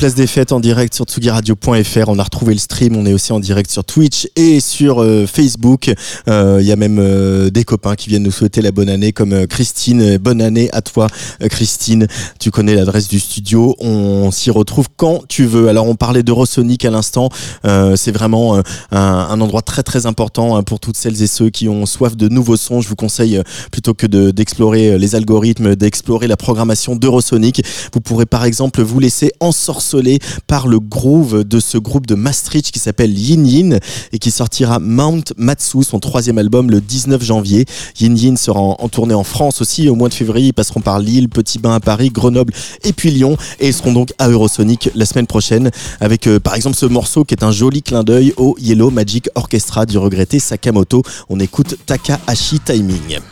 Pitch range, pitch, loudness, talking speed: 105-125 Hz, 115 Hz, -12 LUFS, 210 wpm